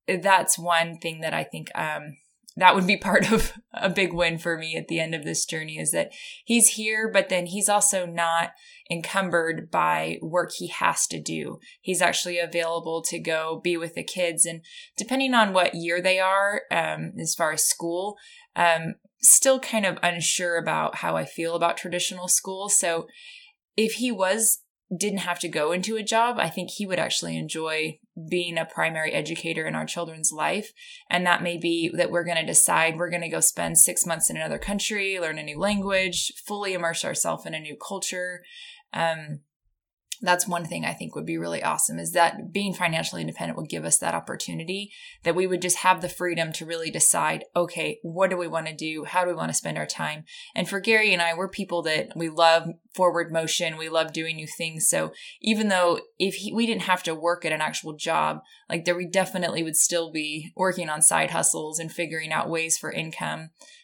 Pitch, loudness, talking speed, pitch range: 175 Hz, -24 LUFS, 205 wpm, 160-195 Hz